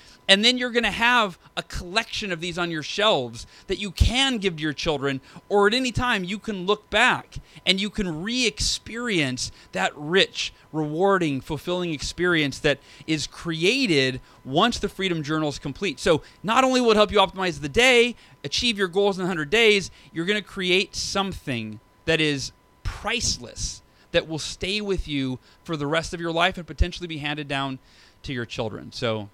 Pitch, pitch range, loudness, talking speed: 175 Hz, 145-205 Hz, -23 LUFS, 185 wpm